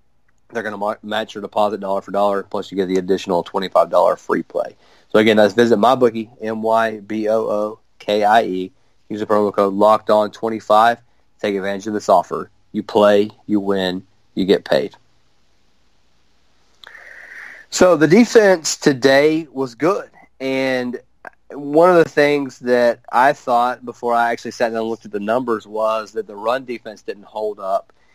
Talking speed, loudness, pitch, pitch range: 155 wpm, -17 LUFS, 110 Hz, 105-120 Hz